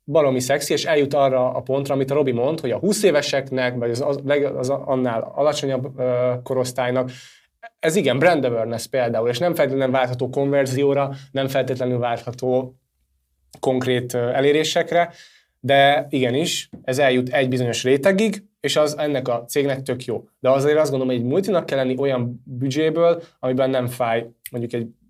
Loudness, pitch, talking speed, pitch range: -21 LUFS, 135 Hz, 155 wpm, 125-145 Hz